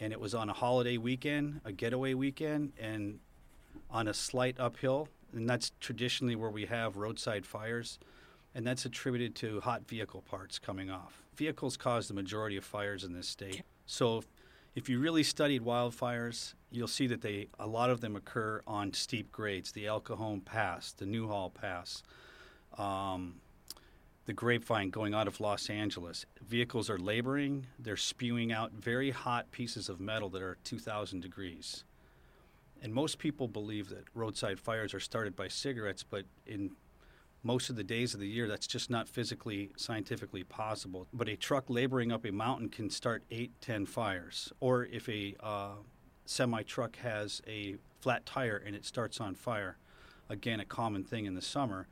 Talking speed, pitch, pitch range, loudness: 170 wpm, 110 Hz, 100-125 Hz, -37 LUFS